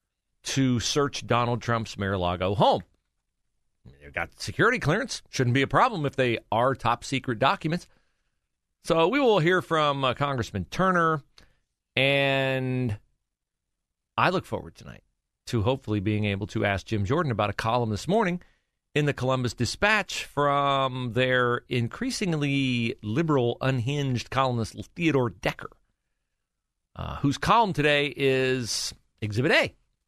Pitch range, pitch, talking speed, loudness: 105-140 Hz, 125 Hz, 140 wpm, -25 LUFS